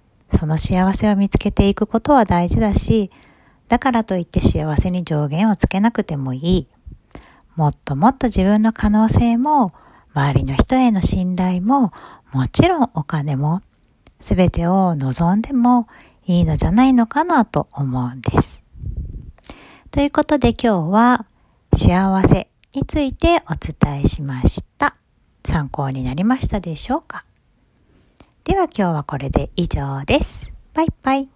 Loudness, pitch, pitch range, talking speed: -18 LUFS, 190 Hz, 155-240 Hz, 275 characters per minute